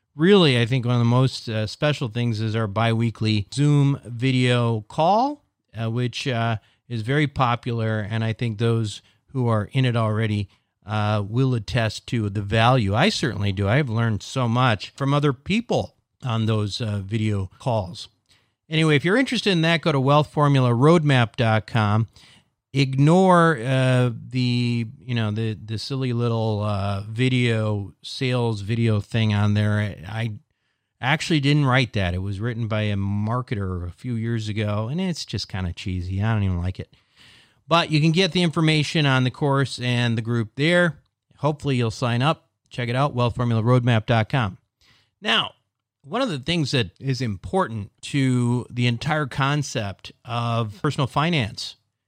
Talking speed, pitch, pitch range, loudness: 160 wpm, 120 Hz, 110-140 Hz, -22 LUFS